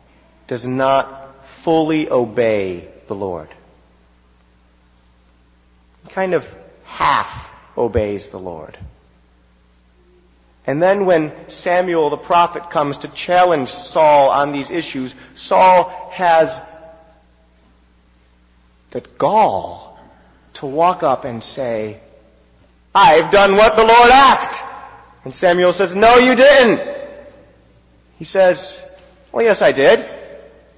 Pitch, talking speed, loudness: 135 Hz, 100 wpm, -14 LUFS